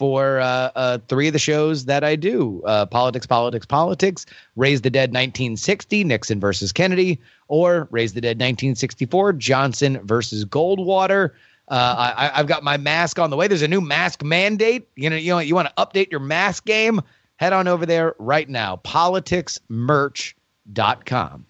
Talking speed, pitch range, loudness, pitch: 170 wpm, 125-175 Hz, -19 LUFS, 150 Hz